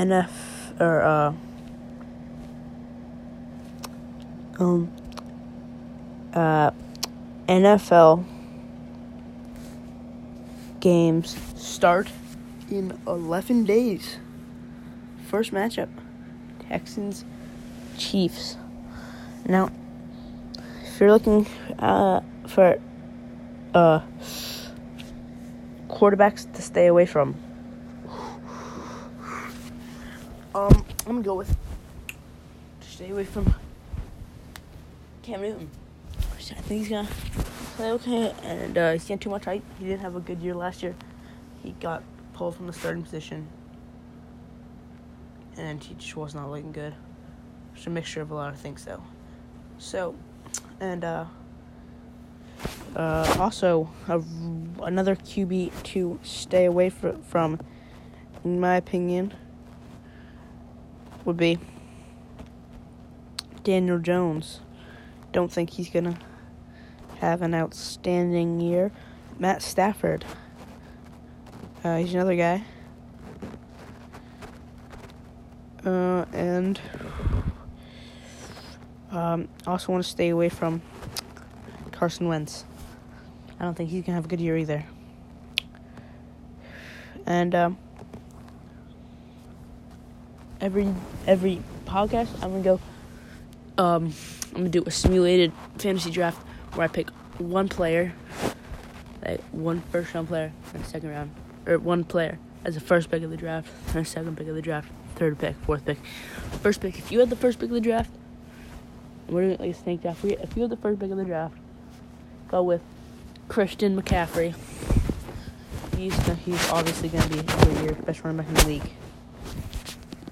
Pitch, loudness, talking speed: 150 Hz, -25 LUFS, 115 wpm